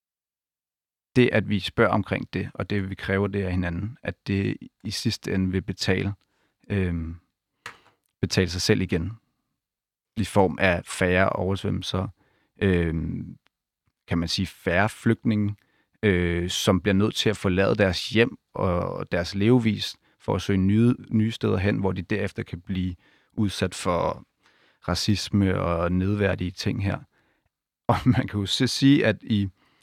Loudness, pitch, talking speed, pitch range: -25 LUFS, 100 Hz, 150 wpm, 90-105 Hz